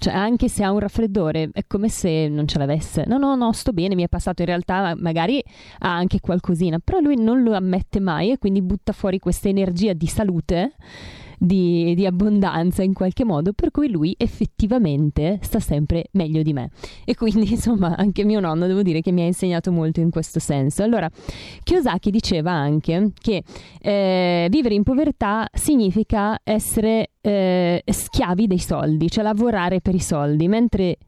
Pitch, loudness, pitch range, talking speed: 190 Hz, -20 LUFS, 170-215 Hz, 180 wpm